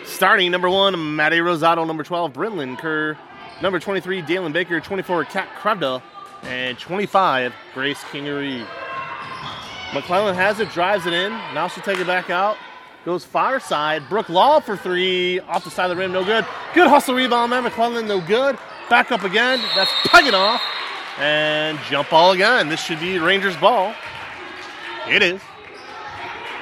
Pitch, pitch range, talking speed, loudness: 185 Hz, 165-225 Hz, 160 wpm, -19 LUFS